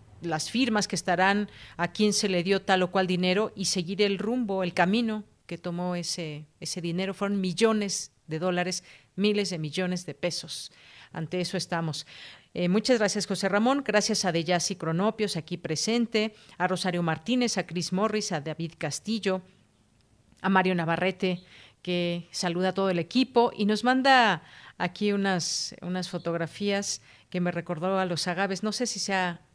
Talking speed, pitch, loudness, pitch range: 170 wpm, 185 Hz, -27 LUFS, 175-205 Hz